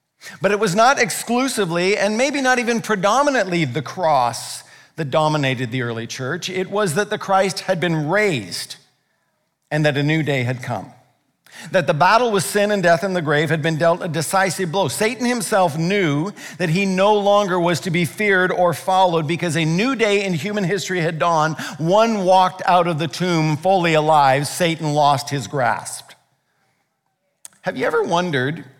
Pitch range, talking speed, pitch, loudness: 155-200 Hz, 180 wpm, 180 Hz, -18 LUFS